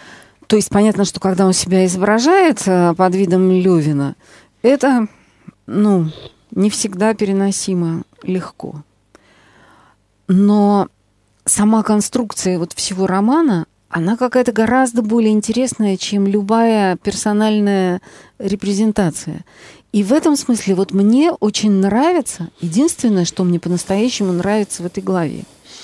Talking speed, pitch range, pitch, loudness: 110 wpm, 185-220 Hz, 200 Hz, -15 LUFS